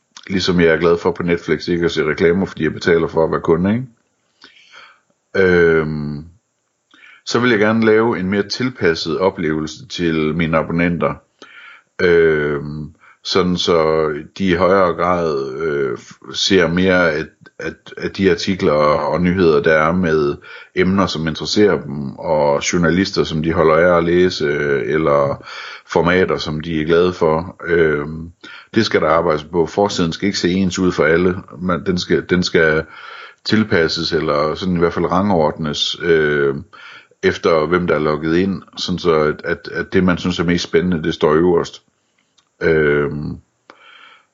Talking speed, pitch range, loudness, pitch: 160 wpm, 80-95 Hz, -16 LUFS, 85 Hz